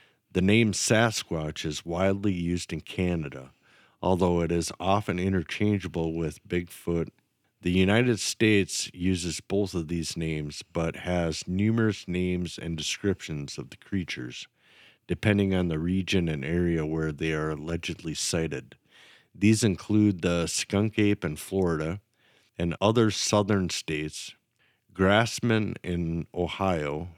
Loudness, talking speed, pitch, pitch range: -27 LUFS, 125 wpm, 90 Hz, 85-105 Hz